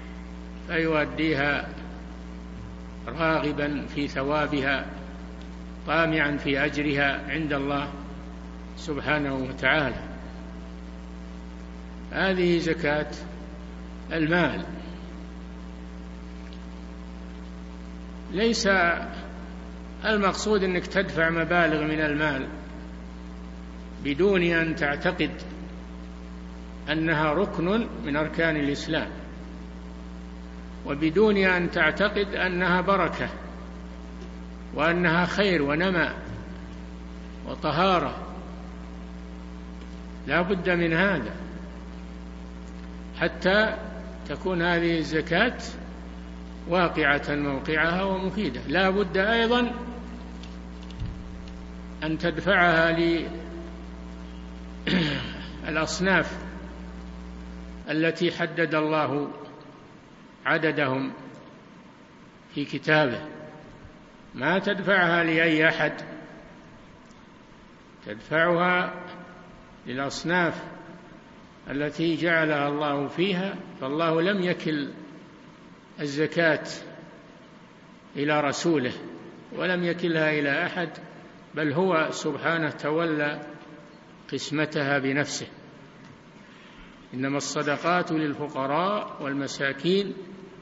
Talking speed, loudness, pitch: 60 wpm, -25 LUFS, 145 Hz